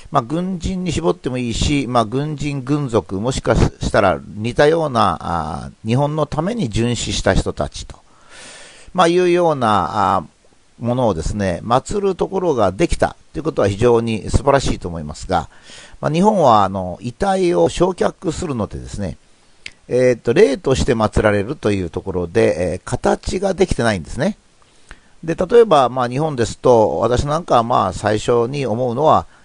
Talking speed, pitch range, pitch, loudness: 325 characters per minute, 105-160 Hz, 125 Hz, -17 LUFS